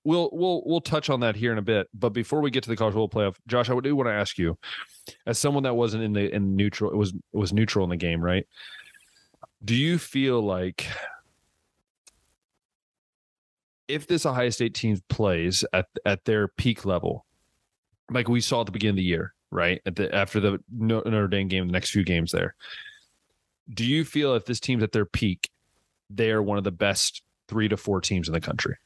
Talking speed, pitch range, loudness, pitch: 210 wpm, 100-120 Hz, -26 LUFS, 105 Hz